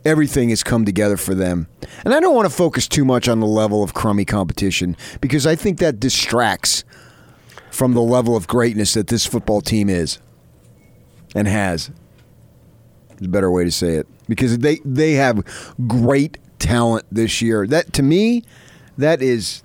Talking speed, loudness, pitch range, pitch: 175 wpm, -17 LUFS, 100-130 Hz, 115 Hz